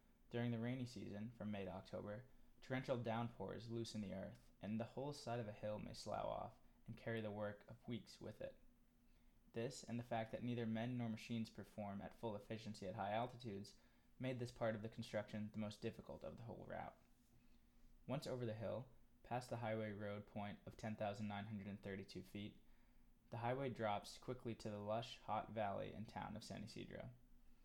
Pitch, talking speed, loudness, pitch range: 110 Hz, 185 wpm, -50 LUFS, 105-120 Hz